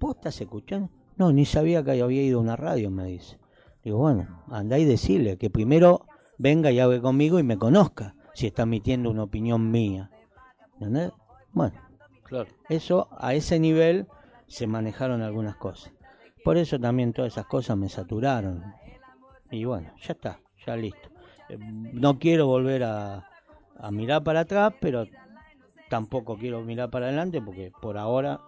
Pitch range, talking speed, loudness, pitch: 110-155 Hz, 160 wpm, -25 LUFS, 125 Hz